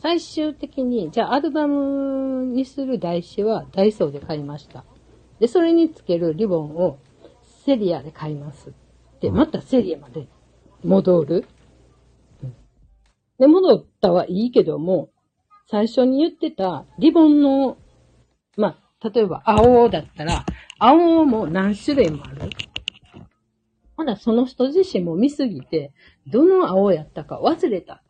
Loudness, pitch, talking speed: -19 LUFS, 220 Hz, 250 characters per minute